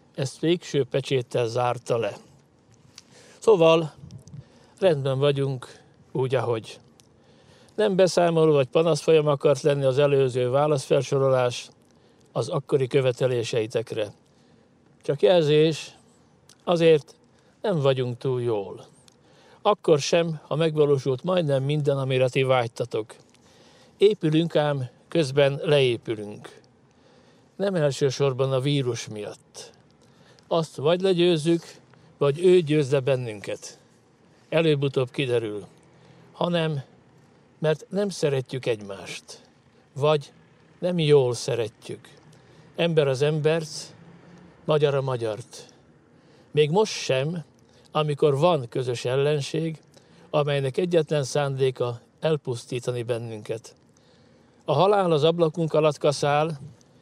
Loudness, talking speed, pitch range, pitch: -24 LUFS, 95 wpm, 130-160 Hz, 145 Hz